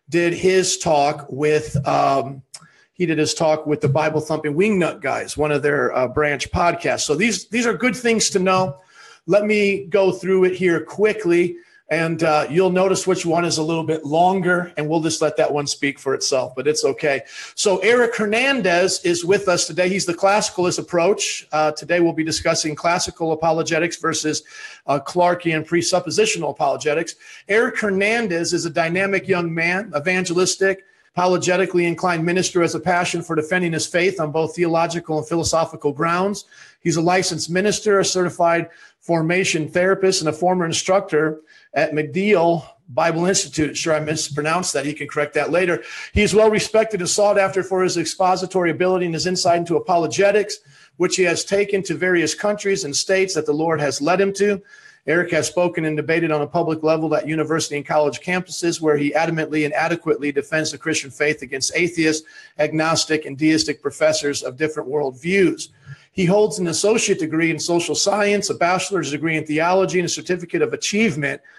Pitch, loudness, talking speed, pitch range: 170 Hz, -19 LUFS, 180 wpm, 155-185 Hz